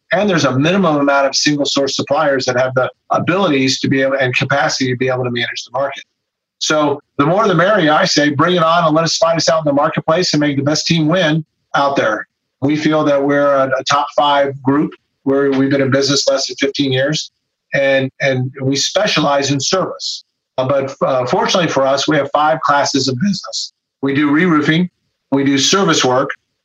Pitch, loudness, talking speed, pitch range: 140 Hz, -14 LUFS, 215 wpm, 135-155 Hz